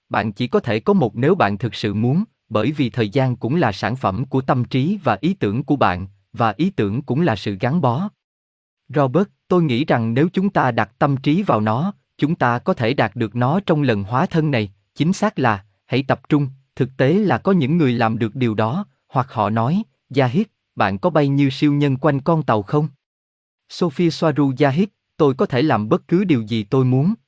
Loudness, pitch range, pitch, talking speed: -19 LUFS, 115-160 Hz, 135 Hz, 220 wpm